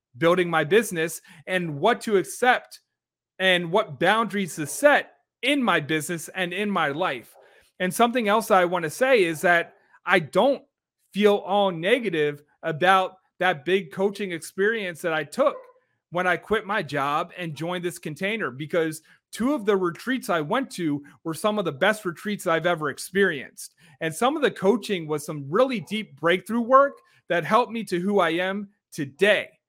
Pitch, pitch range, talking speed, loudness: 185 Hz, 165-215 Hz, 175 wpm, -24 LUFS